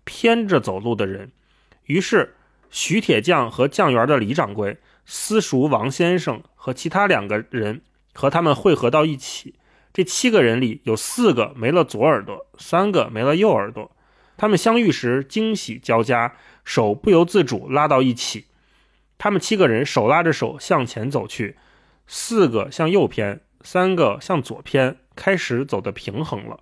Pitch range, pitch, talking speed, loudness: 120-180 Hz, 135 Hz, 235 characters per minute, -20 LUFS